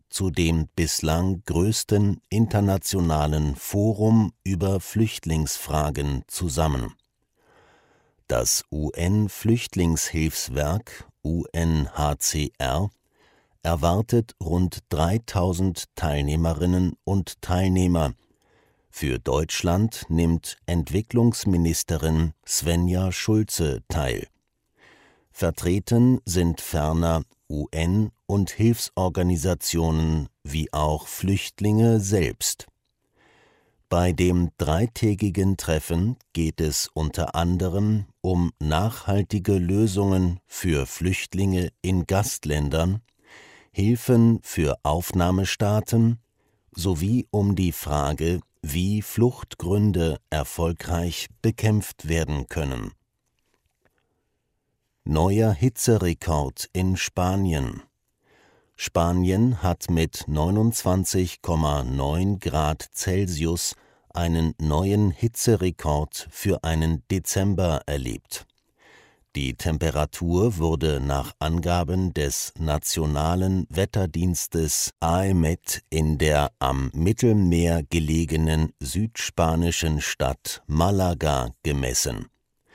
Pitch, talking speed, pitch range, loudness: 85 Hz, 70 wpm, 80-100 Hz, -24 LUFS